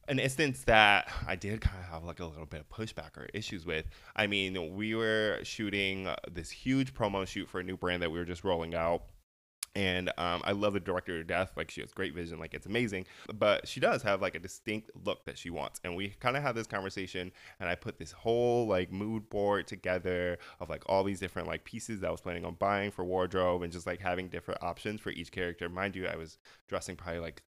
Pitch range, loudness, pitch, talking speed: 85-105 Hz, -34 LUFS, 95 Hz, 240 wpm